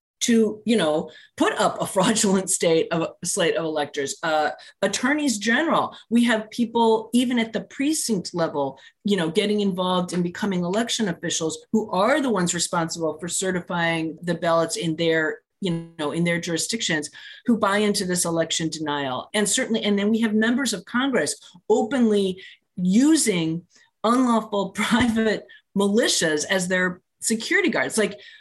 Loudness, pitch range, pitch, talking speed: -22 LUFS, 165-225 Hz, 195 Hz, 150 wpm